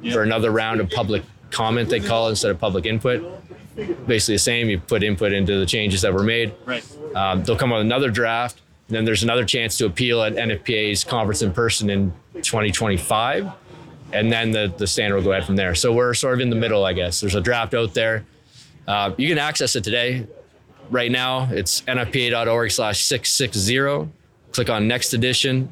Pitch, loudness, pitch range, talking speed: 115 Hz, -20 LUFS, 105-125 Hz, 195 wpm